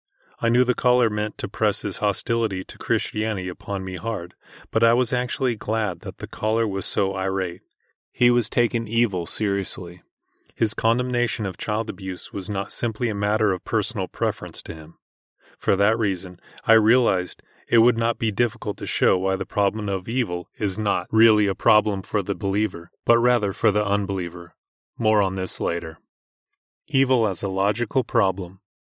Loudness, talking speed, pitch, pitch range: -23 LUFS, 175 wpm, 105 Hz, 95-115 Hz